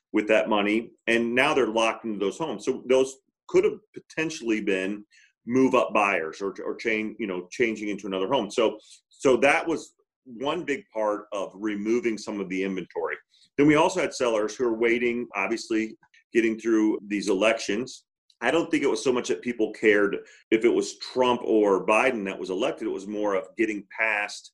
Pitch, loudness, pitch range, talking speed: 110 Hz, -25 LUFS, 105-120 Hz, 195 wpm